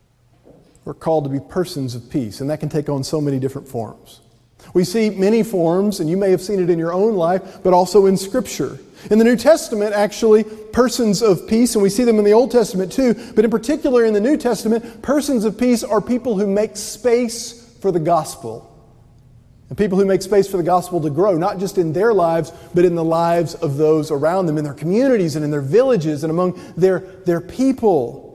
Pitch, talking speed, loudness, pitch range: 185 Hz, 220 wpm, -17 LUFS, 160-220 Hz